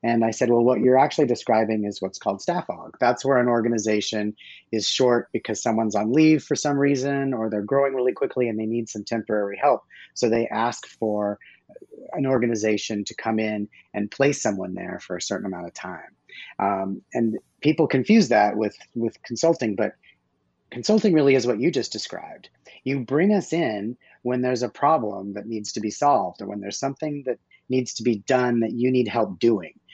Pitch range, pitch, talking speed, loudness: 105-130 Hz, 115 Hz, 200 wpm, -23 LUFS